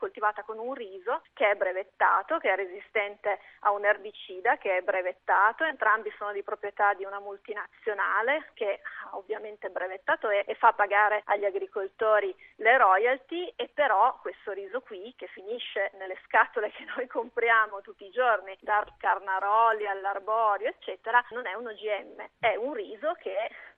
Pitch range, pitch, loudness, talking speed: 200-235 Hz, 210 Hz, -28 LUFS, 155 wpm